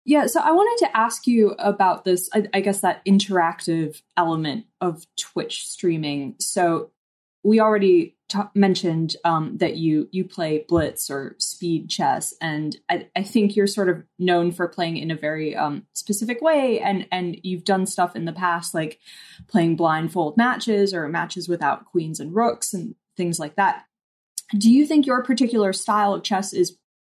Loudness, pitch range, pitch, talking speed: -22 LUFS, 165-205 Hz, 180 Hz, 175 wpm